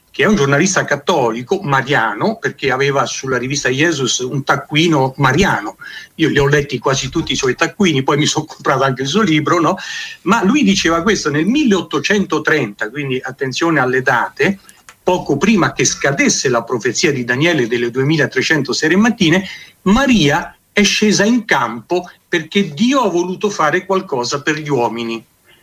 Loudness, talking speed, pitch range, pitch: -15 LUFS, 160 wpm, 135-190 Hz, 155 Hz